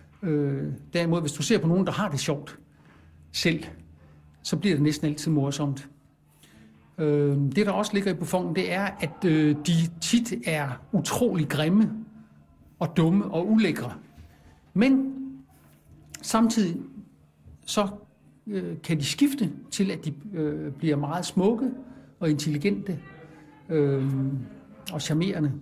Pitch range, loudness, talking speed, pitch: 140-195 Hz, -26 LUFS, 135 wpm, 155 Hz